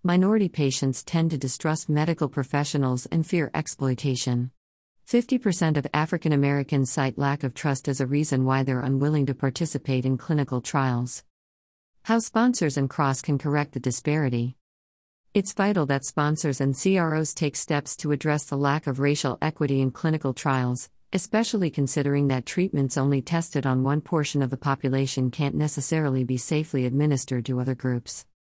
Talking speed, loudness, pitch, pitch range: 160 wpm, -25 LUFS, 140 Hz, 130-155 Hz